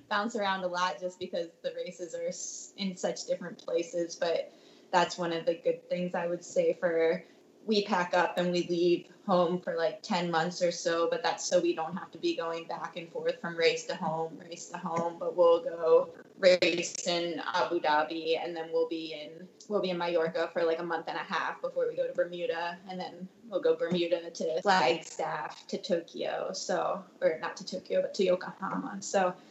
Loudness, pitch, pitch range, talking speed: -31 LUFS, 180 Hz, 170-220 Hz, 205 wpm